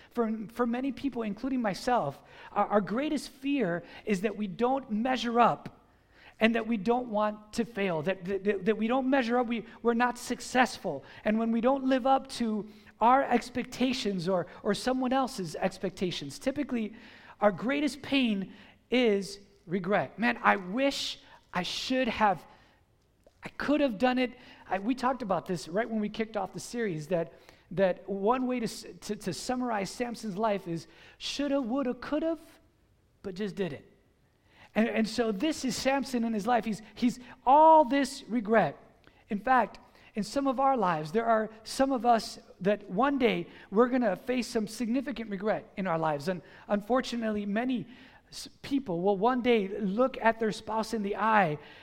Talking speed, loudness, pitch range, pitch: 170 wpm, -29 LUFS, 205-250 Hz, 225 Hz